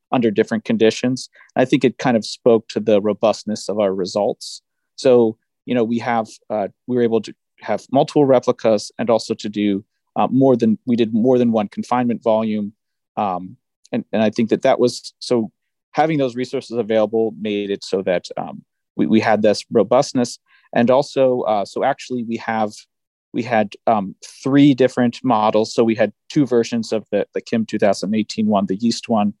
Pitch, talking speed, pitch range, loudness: 115 Hz, 190 wpm, 110-125 Hz, -19 LUFS